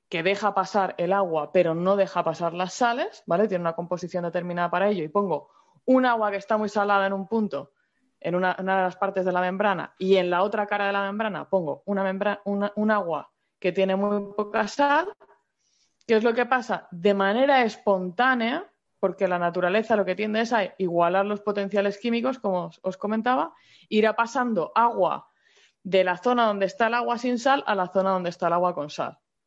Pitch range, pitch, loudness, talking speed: 185-225 Hz, 200 Hz, -25 LUFS, 210 wpm